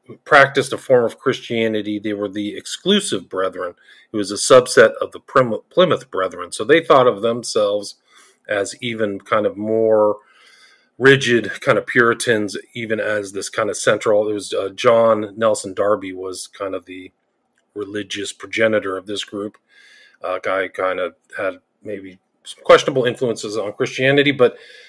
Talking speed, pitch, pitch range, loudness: 160 wpm, 110 Hz, 105-140 Hz, -18 LUFS